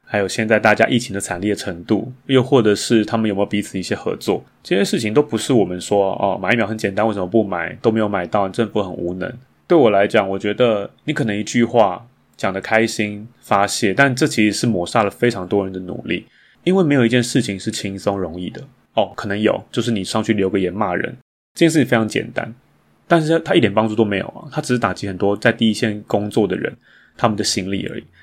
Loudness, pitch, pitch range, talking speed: -18 LUFS, 110 Hz, 100-120 Hz, 345 characters per minute